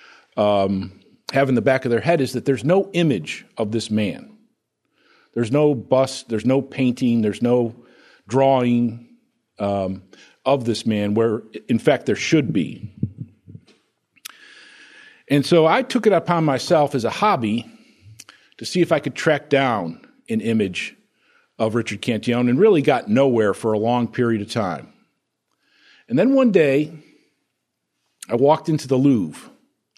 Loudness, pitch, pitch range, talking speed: -20 LUFS, 130 Hz, 115-165 Hz, 150 wpm